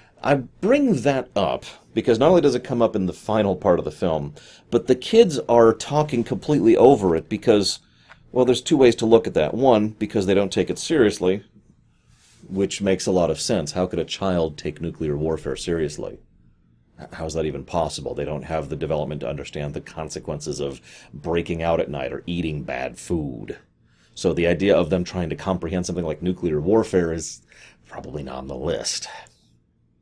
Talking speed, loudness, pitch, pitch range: 195 wpm, -22 LUFS, 90 Hz, 75-110 Hz